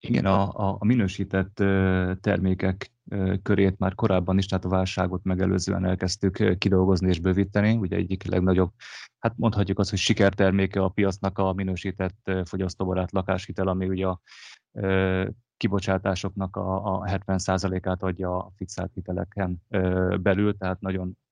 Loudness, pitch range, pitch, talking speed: -25 LUFS, 95-100 Hz, 95 Hz, 125 wpm